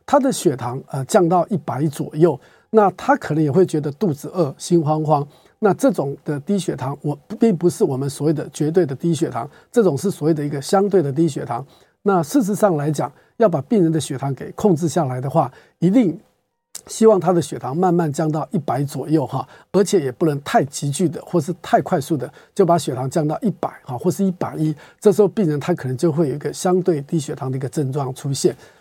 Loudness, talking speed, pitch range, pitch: -20 LUFS, 315 characters per minute, 145-185 Hz, 165 Hz